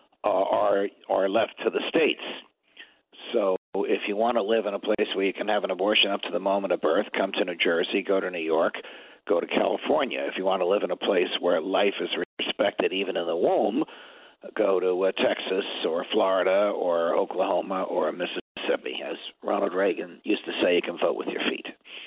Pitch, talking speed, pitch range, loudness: 100 Hz, 210 wpm, 95-100 Hz, -26 LUFS